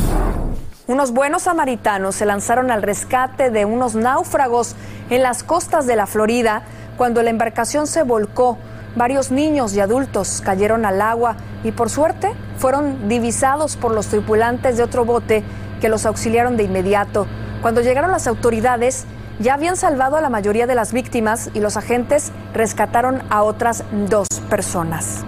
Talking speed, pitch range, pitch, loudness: 155 wpm, 215-260 Hz, 235 Hz, -18 LUFS